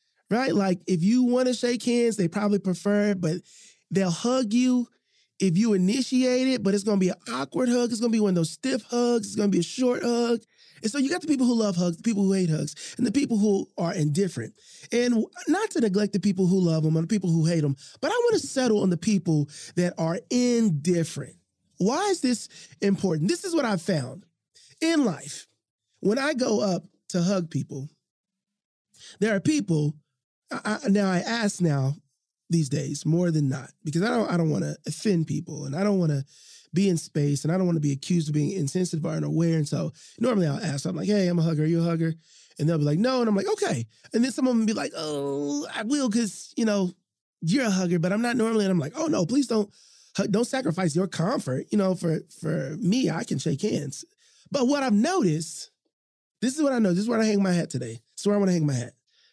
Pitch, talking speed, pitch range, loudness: 190 Hz, 245 wpm, 160-235 Hz, -25 LUFS